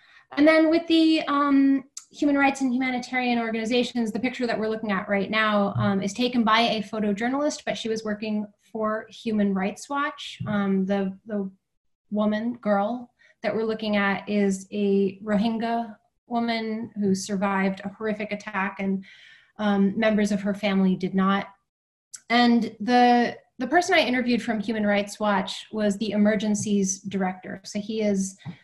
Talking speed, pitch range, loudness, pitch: 155 wpm, 200-240 Hz, -24 LUFS, 215 Hz